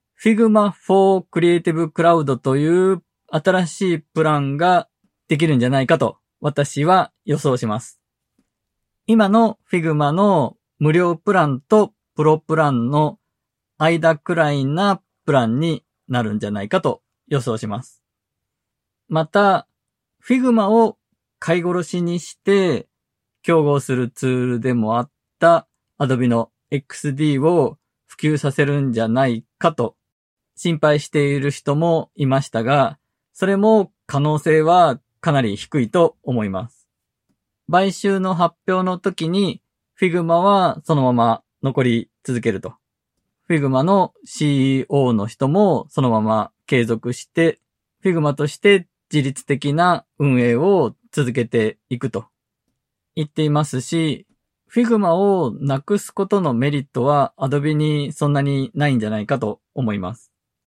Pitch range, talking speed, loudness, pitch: 125-175 Hz, 275 characters per minute, -19 LUFS, 150 Hz